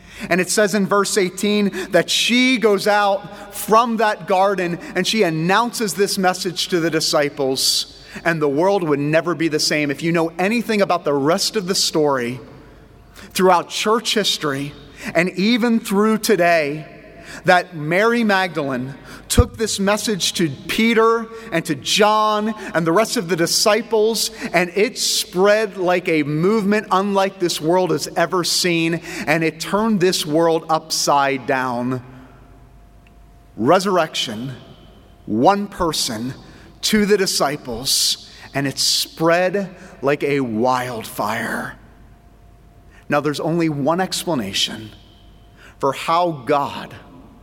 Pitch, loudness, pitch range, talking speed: 175 Hz, -18 LUFS, 150-205 Hz, 130 wpm